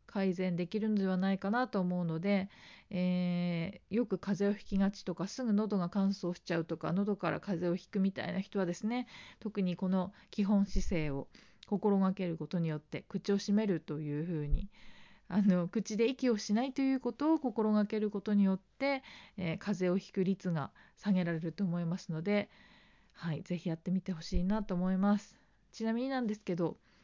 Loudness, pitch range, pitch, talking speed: -34 LUFS, 175-210 Hz, 195 Hz, 365 characters per minute